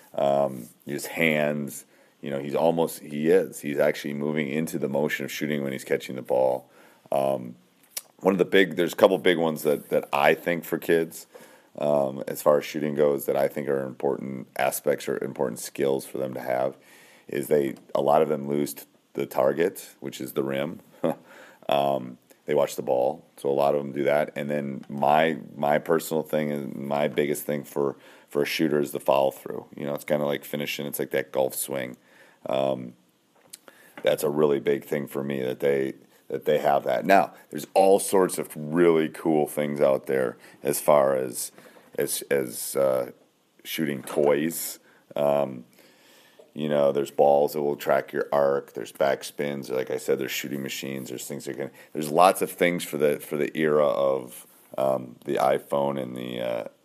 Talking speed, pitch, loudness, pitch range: 190 wpm, 70 Hz, -25 LUFS, 65-75 Hz